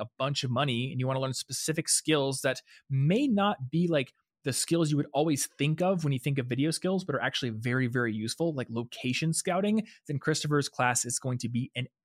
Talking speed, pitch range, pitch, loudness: 230 wpm, 125-160 Hz, 135 Hz, -29 LUFS